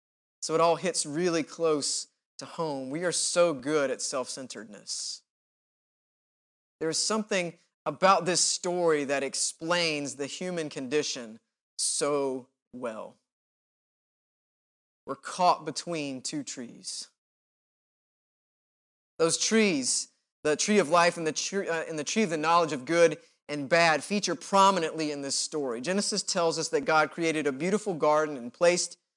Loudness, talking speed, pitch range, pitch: -27 LUFS, 140 wpm, 150-175 Hz, 165 Hz